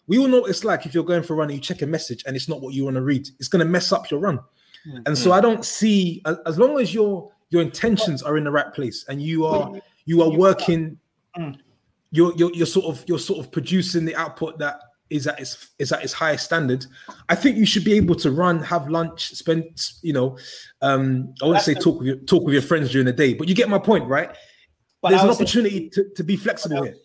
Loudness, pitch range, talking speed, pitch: -21 LUFS, 145-185 Hz, 260 wpm, 165 Hz